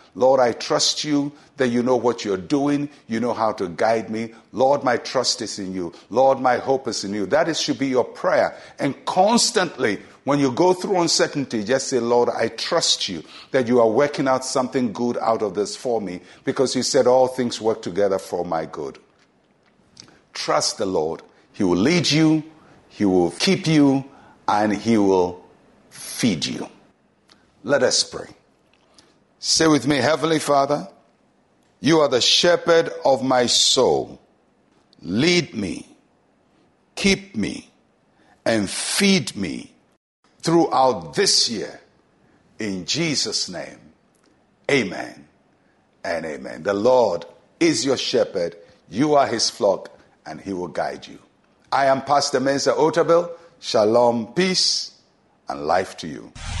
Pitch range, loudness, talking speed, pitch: 115-160 Hz, -20 LUFS, 150 wpm, 135 Hz